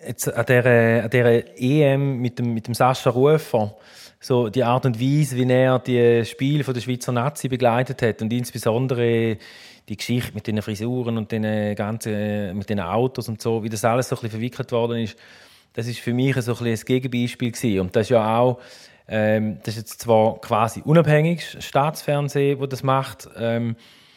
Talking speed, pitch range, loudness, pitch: 185 wpm, 115-130 Hz, -21 LUFS, 120 Hz